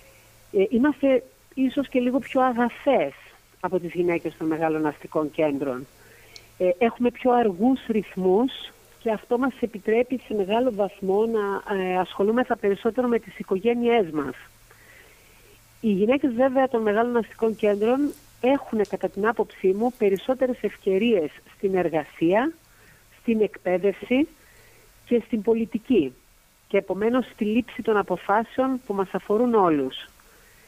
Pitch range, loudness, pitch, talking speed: 190-245 Hz, -24 LUFS, 215 Hz, 125 wpm